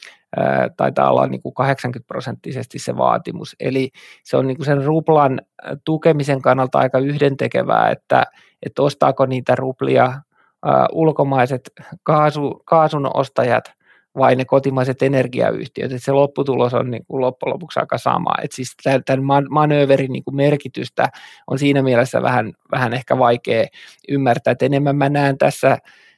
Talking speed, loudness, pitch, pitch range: 140 wpm, -18 LUFS, 135 Hz, 130-145 Hz